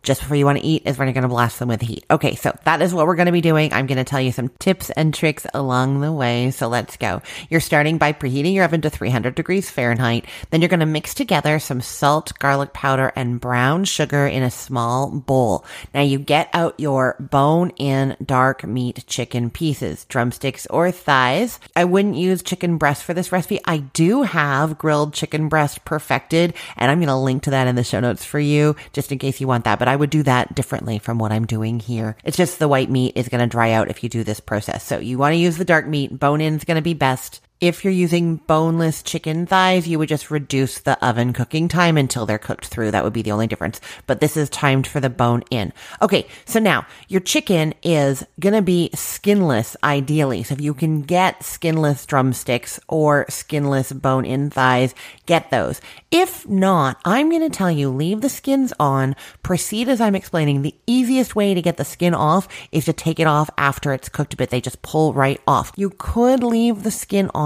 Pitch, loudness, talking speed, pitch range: 145 Hz, -19 LUFS, 230 wpm, 130-165 Hz